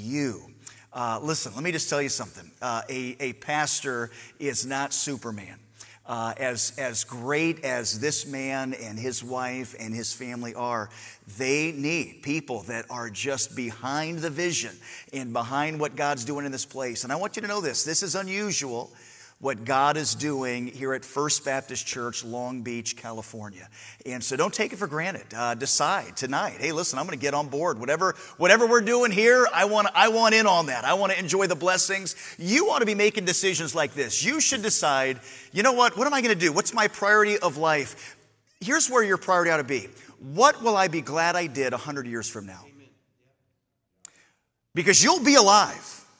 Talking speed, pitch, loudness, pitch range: 195 wpm, 140 Hz, -24 LUFS, 120-180 Hz